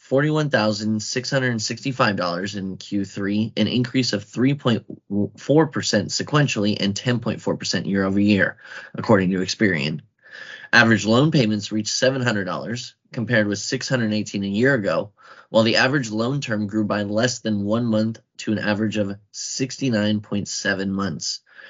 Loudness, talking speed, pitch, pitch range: -21 LUFS, 120 wpm, 110 Hz, 100-125 Hz